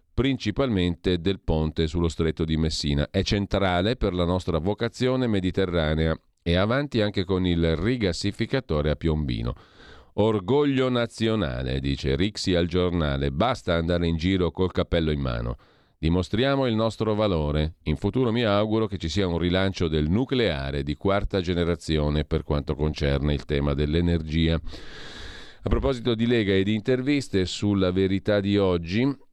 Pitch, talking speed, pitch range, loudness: 90 Hz, 145 wpm, 80-105 Hz, -25 LUFS